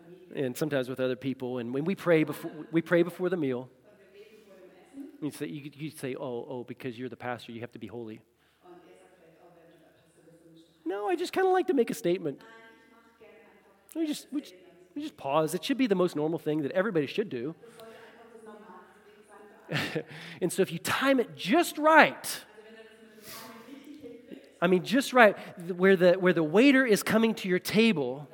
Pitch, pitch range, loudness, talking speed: 180 Hz, 155-225 Hz, -27 LUFS, 165 wpm